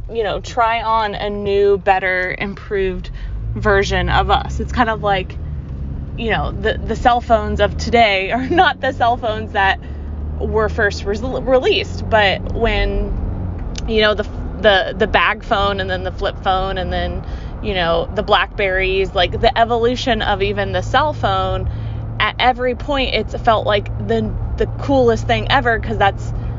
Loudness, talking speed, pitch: -17 LUFS, 165 wpm, 175 Hz